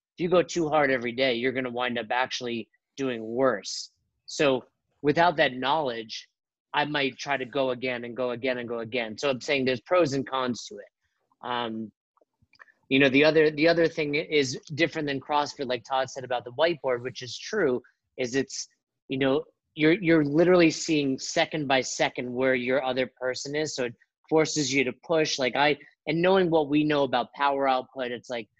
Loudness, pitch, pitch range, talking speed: -26 LUFS, 135 Hz, 125-155 Hz, 195 wpm